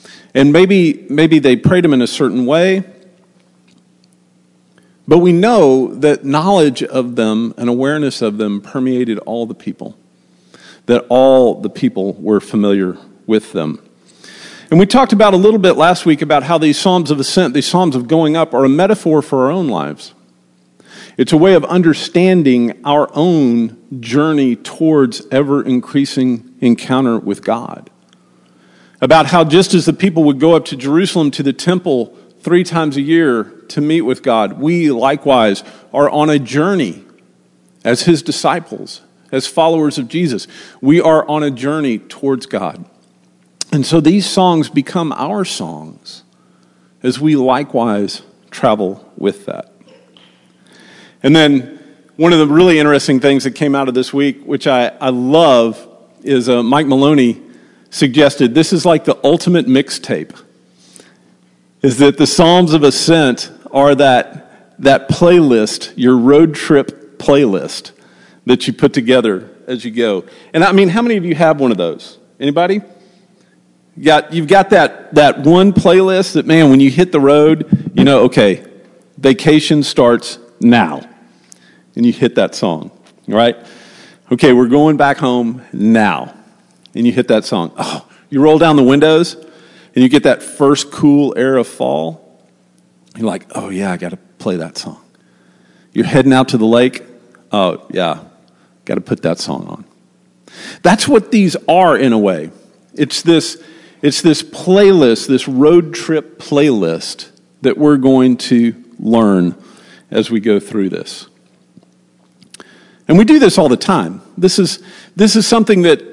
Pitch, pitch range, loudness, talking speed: 140 Hz, 120-160 Hz, -12 LUFS, 160 wpm